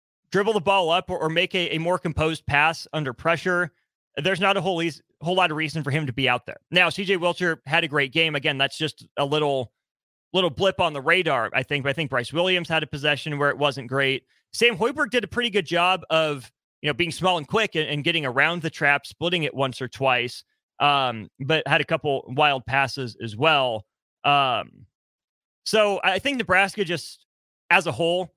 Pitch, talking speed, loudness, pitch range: 160 Hz, 215 wpm, -23 LUFS, 140-180 Hz